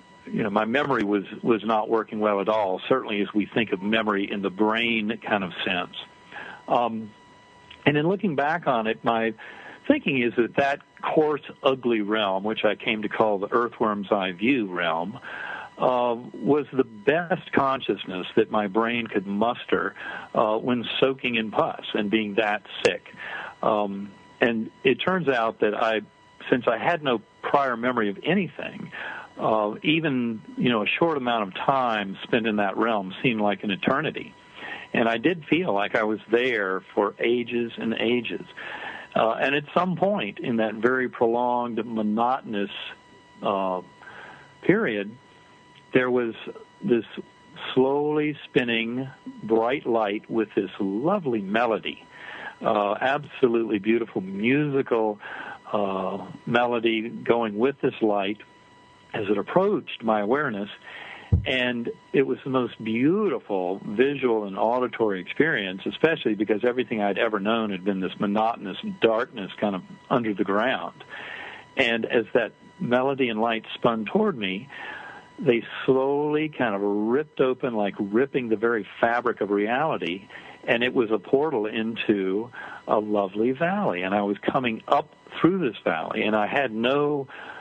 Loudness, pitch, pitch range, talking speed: -25 LUFS, 115 Hz, 105-130 Hz, 150 wpm